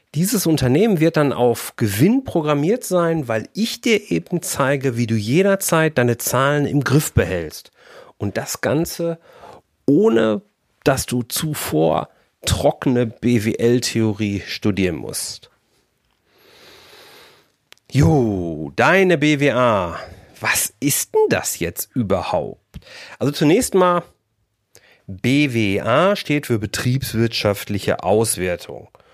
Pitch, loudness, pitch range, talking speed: 130 Hz, -19 LUFS, 110-165 Hz, 100 wpm